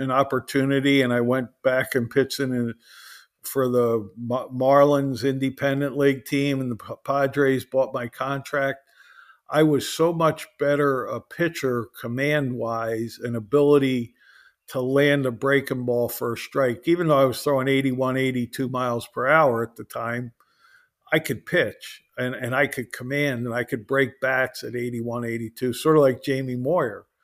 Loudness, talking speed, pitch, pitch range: -23 LUFS, 165 wpm, 130 Hz, 120-140 Hz